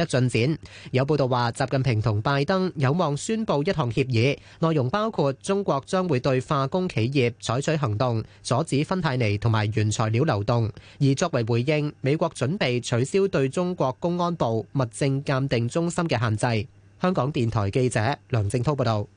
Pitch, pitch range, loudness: 135 Hz, 120-155 Hz, -24 LUFS